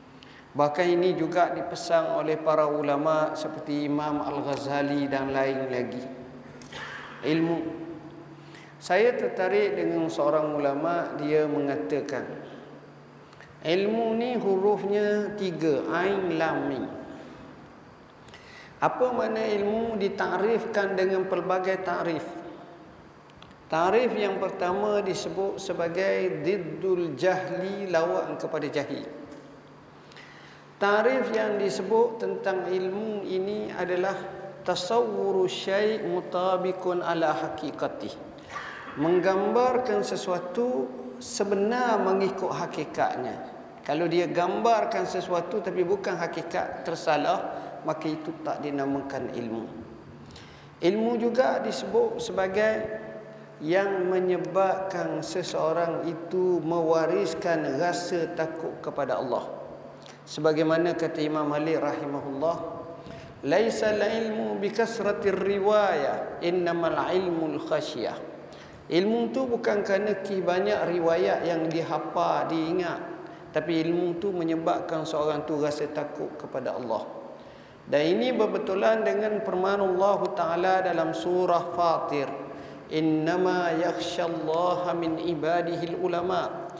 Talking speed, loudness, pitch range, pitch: 95 wpm, -27 LUFS, 155-195 Hz, 175 Hz